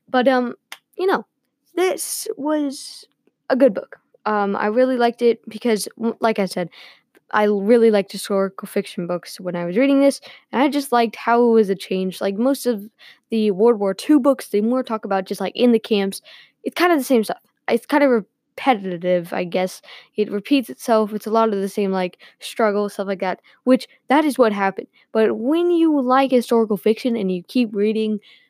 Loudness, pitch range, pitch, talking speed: -20 LUFS, 200-260 Hz, 225 Hz, 200 wpm